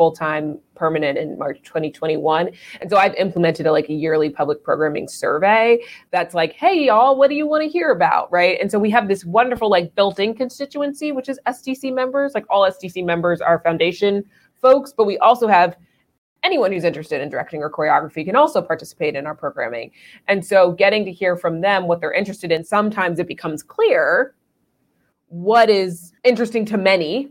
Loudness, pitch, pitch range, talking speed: -18 LUFS, 195 Hz, 170-240 Hz, 190 wpm